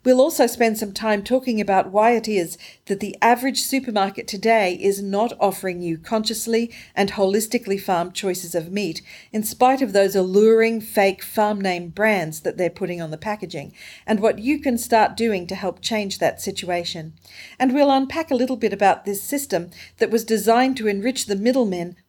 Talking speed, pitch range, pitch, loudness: 185 wpm, 190-235 Hz, 210 Hz, -21 LUFS